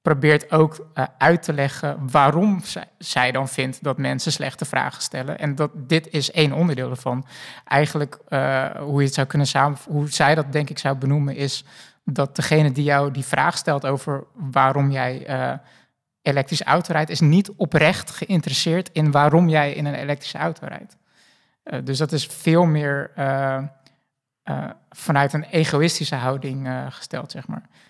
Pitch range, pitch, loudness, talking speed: 135-155 Hz, 145 Hz, -21 LUFS, 170 wpm